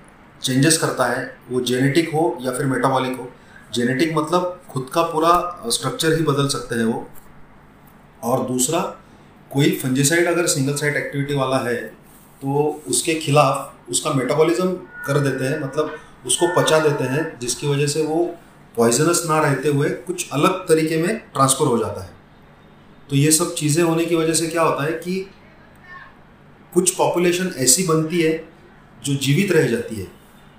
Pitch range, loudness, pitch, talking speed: 130-165 Hz, -19 LUFS, 150 Hz, 160 wpm